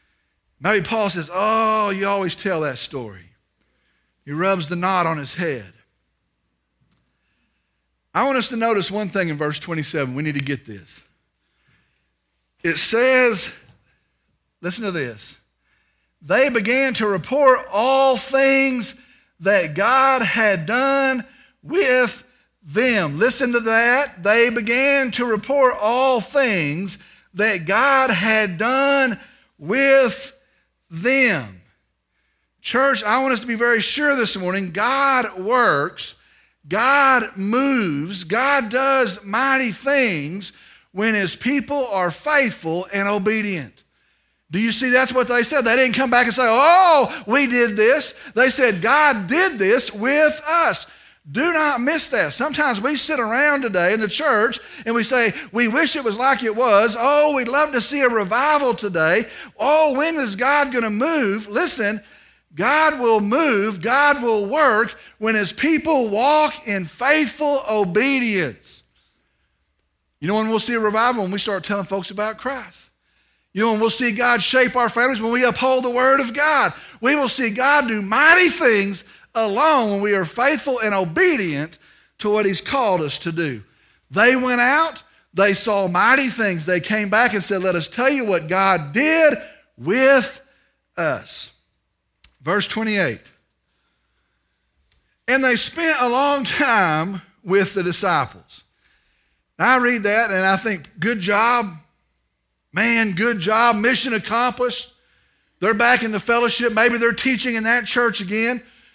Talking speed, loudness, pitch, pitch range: 150 wpm, -18 LUFS, 230 Hz, 195-265 Hz